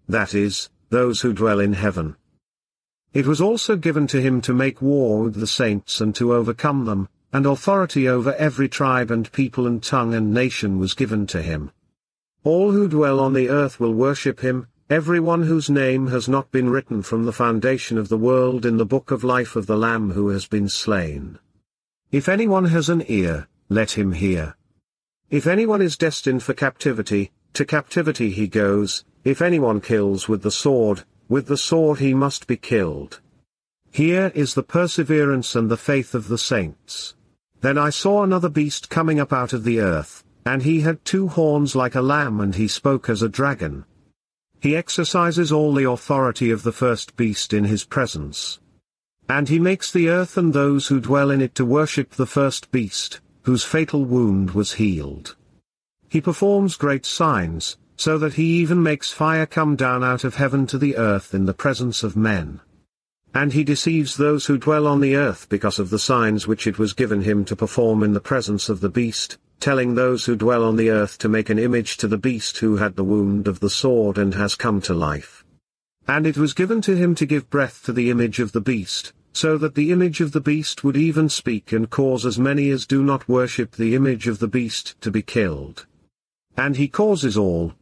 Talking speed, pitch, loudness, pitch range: 200 wpm, 125 Hz, -20 LUFS, 110-145 Hz